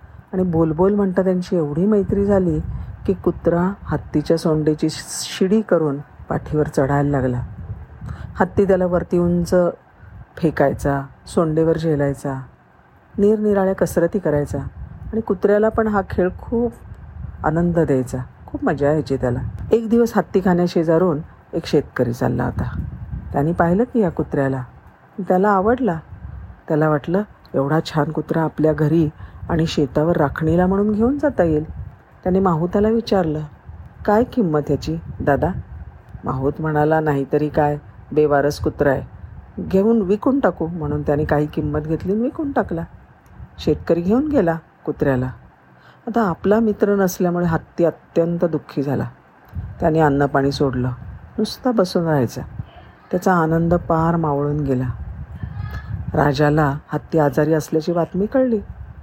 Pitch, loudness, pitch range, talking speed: 160 Hz, -19 LUFS, 145-190 Hz, 125 wpm